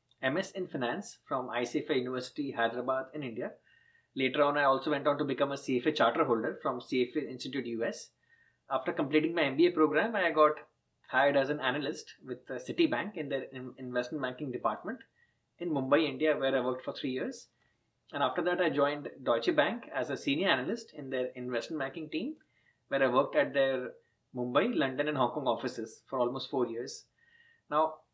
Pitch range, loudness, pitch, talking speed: 130-155 Hz, -32 LUFS, 145 Hz, 180 wpm